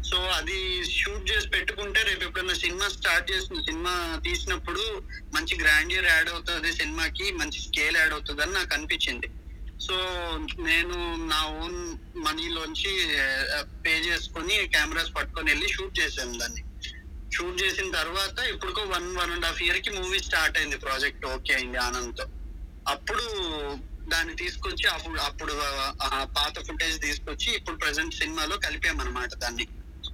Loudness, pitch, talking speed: -27 LUFS, 175 Hz, 130 wpm